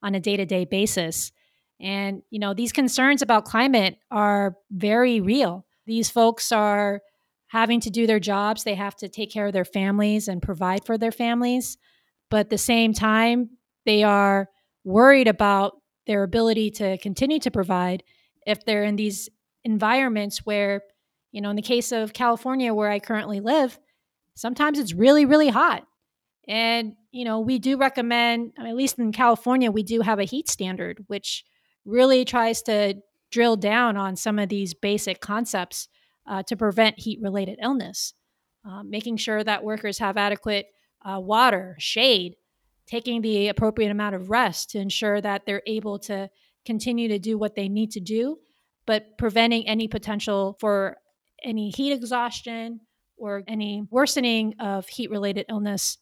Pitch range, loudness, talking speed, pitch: 200-235 Hz, -23 LUFS, 160 wpm, 215 Hz